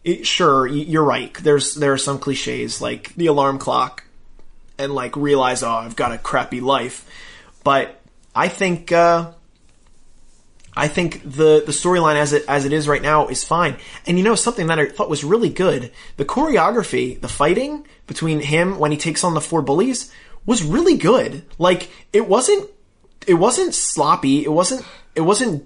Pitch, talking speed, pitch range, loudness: 155 Hz, 180 wpm, 145-180 Hz, -18 LUFS